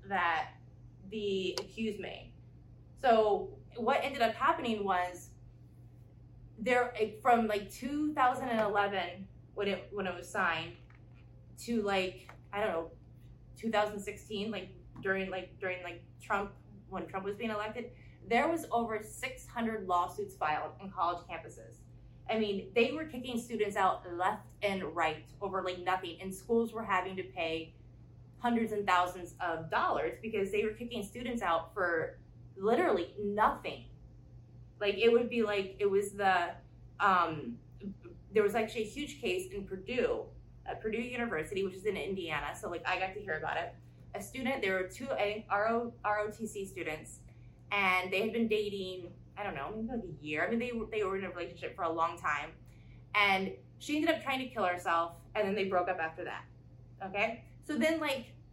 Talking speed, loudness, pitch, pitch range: 165 wpm, -34 LUFS, 195 Hz, 165-220 Hz